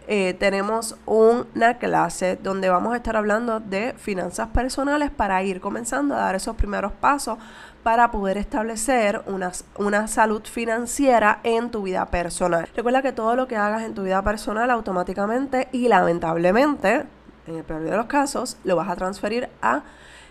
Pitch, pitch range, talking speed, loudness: 220 Hz, 195-240 Hz, 160 wpm, -22 LUFS